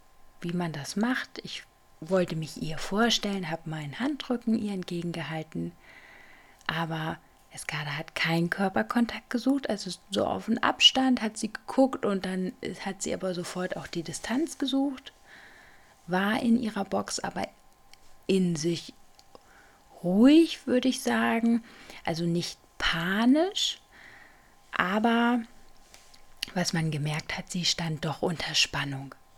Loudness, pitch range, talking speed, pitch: -28 LUFS, 170-235 Hz, 125 wpm, 195 Hz